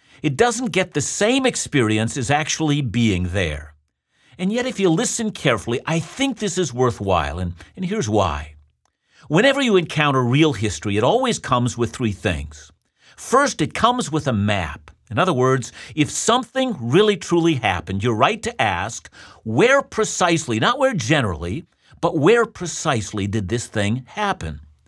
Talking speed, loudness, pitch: 160 wpm, -20 LUFS, 130 Hz